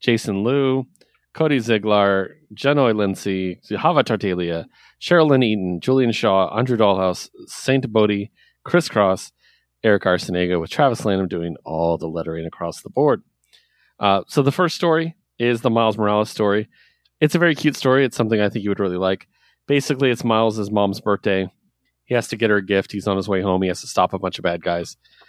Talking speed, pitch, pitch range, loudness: 185 wpm, 105 Hz, 95-130 Hz, -20 LUFS